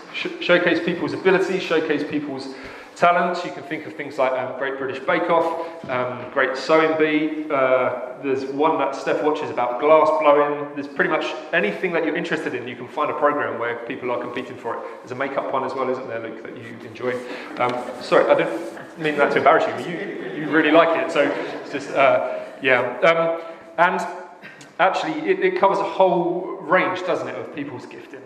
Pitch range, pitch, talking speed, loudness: 130-170 Hz, 155 Hz, 200 wpm, -21 LUFS